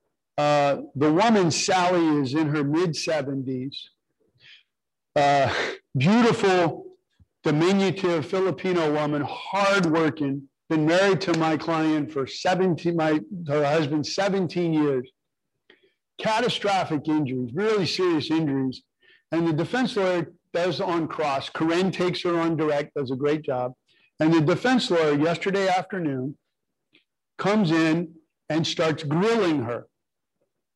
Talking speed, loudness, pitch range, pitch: 115 wpm, -24 LUFS, 150-185 Hz, 165 Hz